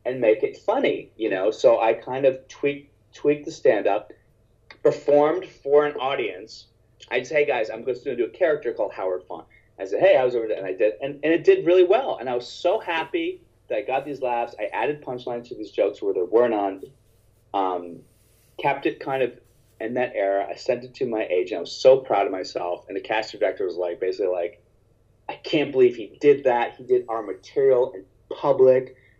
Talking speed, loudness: 220 wpm, -23 LUFS